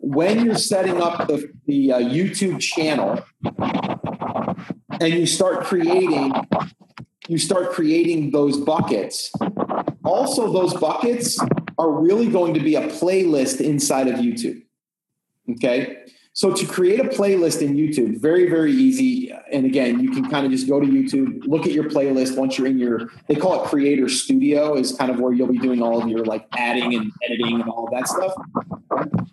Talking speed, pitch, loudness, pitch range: 170 wpm, 160 Hz, -20 LUFS, 135-195 Hz